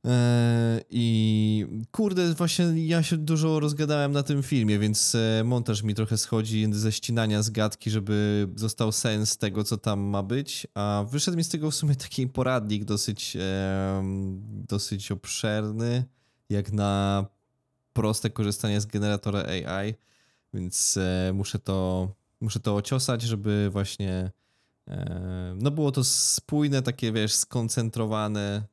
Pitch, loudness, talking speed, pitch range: 110 Hz, -26 LUFS, 125 wpm, 105-125 Hz